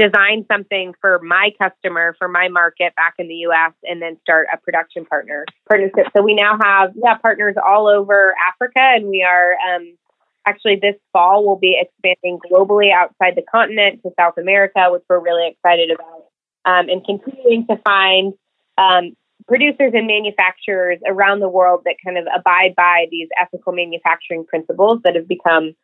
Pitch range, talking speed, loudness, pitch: 175-205 Hz, 175 wpm, -14 LUFS, 185 Hz